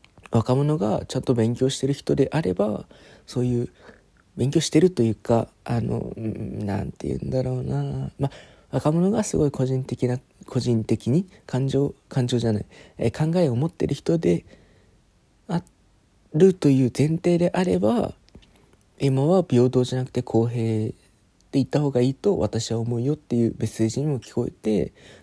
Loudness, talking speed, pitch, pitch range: -24 LUFS, 305 characters per minute, 125 Hz, 110-140 Hz